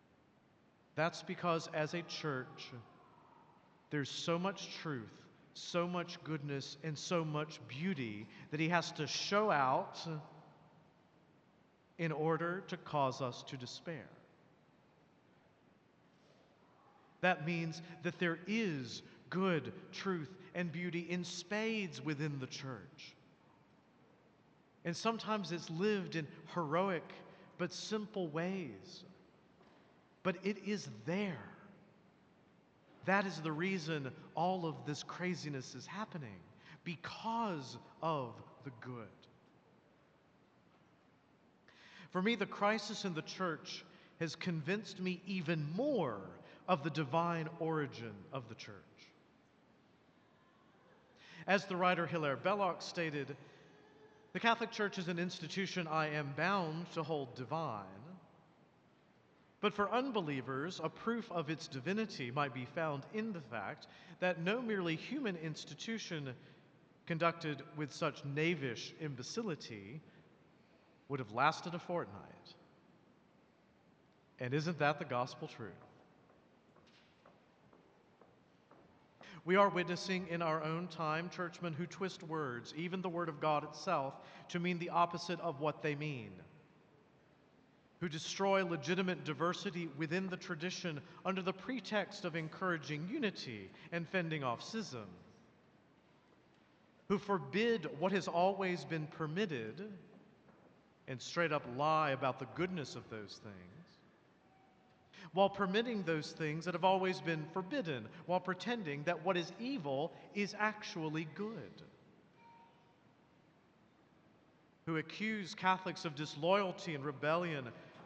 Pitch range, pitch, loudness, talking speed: 150-185 Hz, 170 Hz, -39 LUFS, 115 wpm